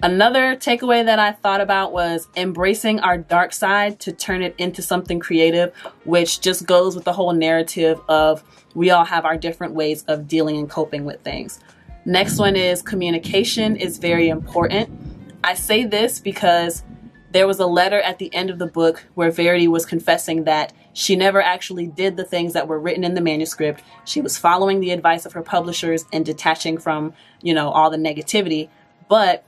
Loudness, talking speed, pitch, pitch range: -18 LUFS, 185 wpm, 175 Hz, 165-190 Hz